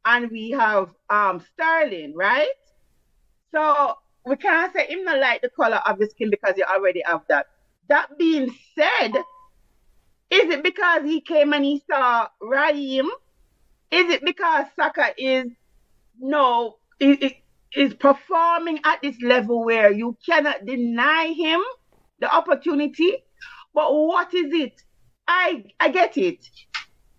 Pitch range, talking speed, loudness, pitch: 250-335 Hz, 135 wpm, -21 LUFS, 295 Hz